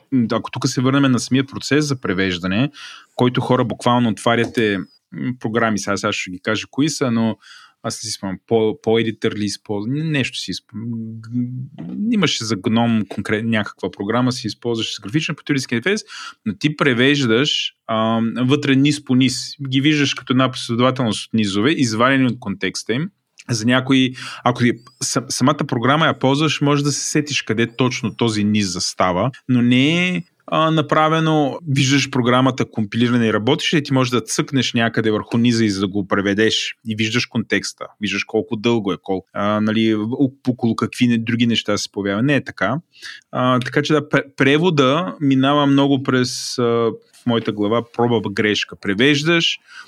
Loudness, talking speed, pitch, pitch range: -18 LUFS, 165 wpm, 125 Hz, 110-140 Hz